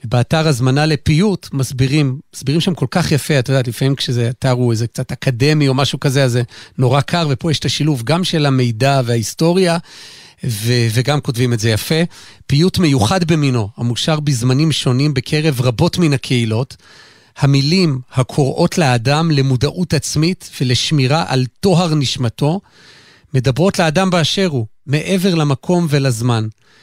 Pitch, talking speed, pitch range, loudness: 140 Hz, 145 wpm, 125-160 Hz, -15 LUFS